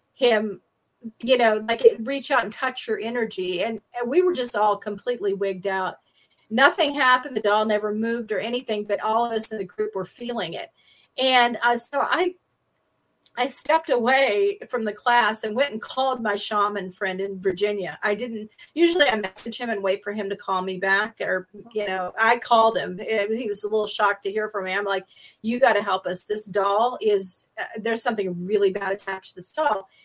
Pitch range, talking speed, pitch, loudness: 200-240 Hz, 210 wpm, 215 Hz, -23 LUFS